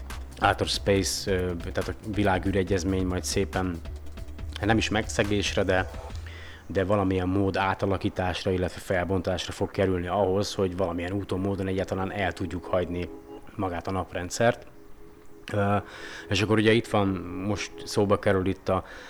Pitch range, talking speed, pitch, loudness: 90-100 Hz, 130 wpm, 95 Hz, -27 LUFS